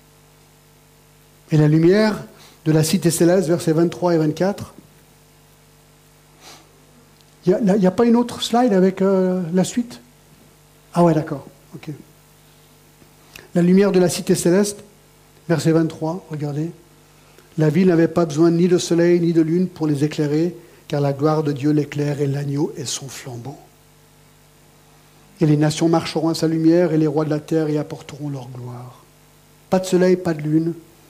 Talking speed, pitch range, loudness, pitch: 160 wpm, 150-180 Hz, -18 LUFS, 160 Hz